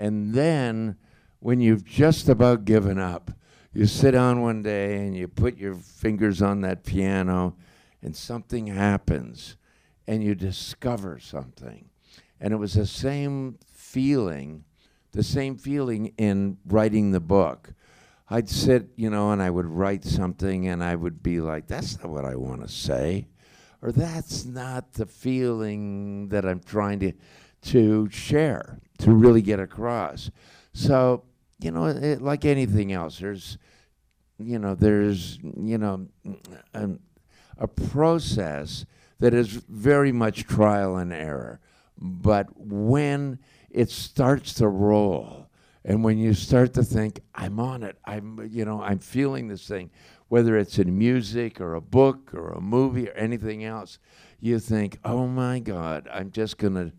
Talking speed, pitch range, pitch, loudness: 150 wpm, 95-120 Hz, 105 Hz, -24 LUFS